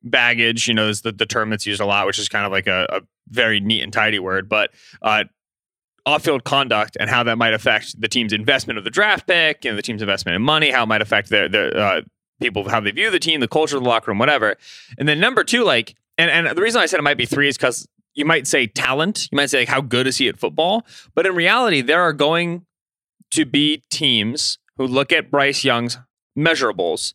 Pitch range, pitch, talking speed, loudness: 110-145 Hz, 120 Hz, 250 wpm, -17 LUFS